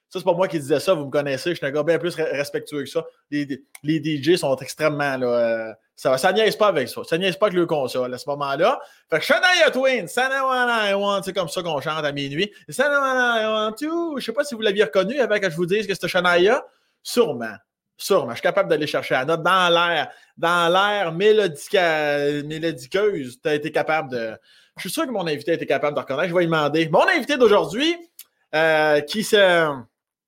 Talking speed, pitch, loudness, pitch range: 225 wpm, 170 Hz, -21 LUFS, 150-210 Hz